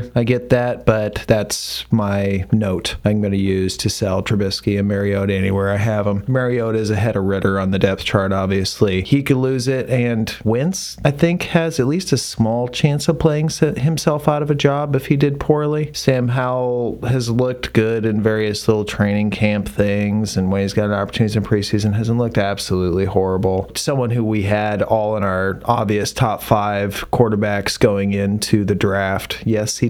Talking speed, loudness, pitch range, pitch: 190 wpm, -18 LUFS, 100-125 Hz, 110 Hz